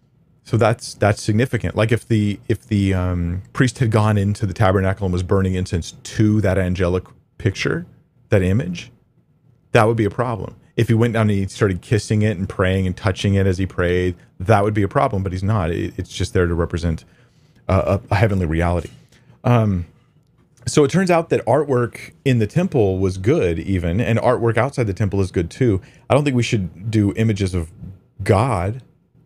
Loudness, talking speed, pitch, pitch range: -19 LUFS, 195 wpm, 105 Hz, 95-120 Hz